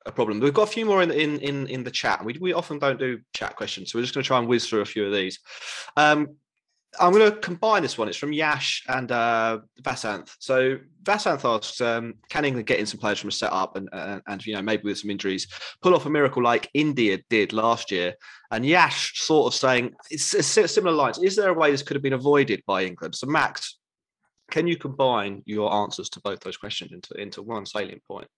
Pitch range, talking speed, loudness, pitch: 110-150 Hz, 240 wpm, -24 LUFS, 130 Hz